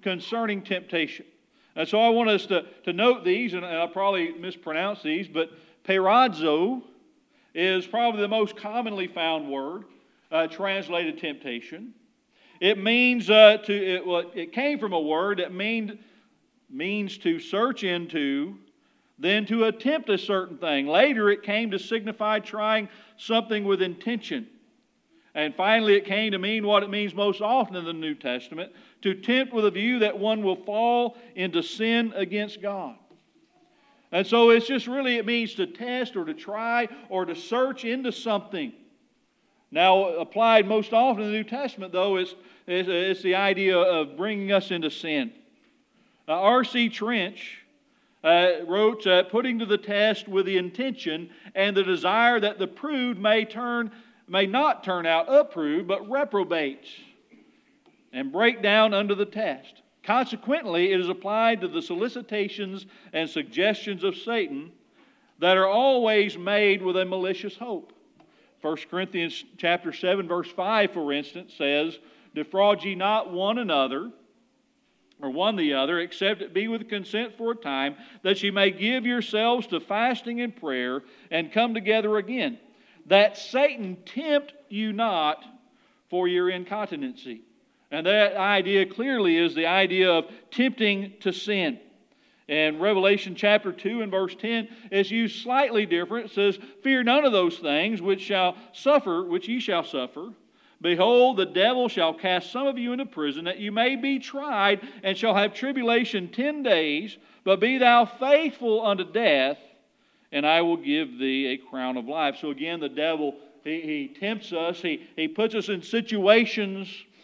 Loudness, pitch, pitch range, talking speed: -24 LUFS, 210 Hz, 185-245 Hz, 160 wpm